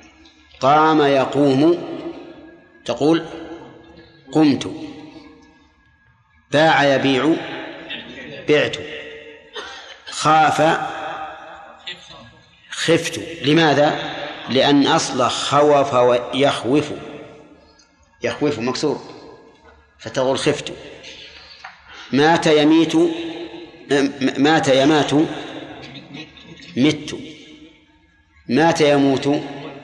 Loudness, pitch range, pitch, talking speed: -17 LUFS, 140-165 Hz, 150 Hz, 50 wpm